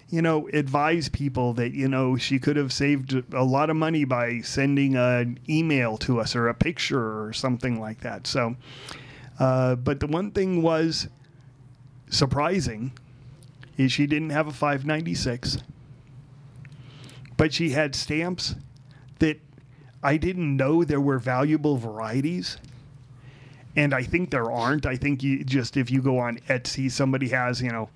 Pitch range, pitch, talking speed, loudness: 130-145 Hz, 135 Hz, 155 wpm, -25 LUFS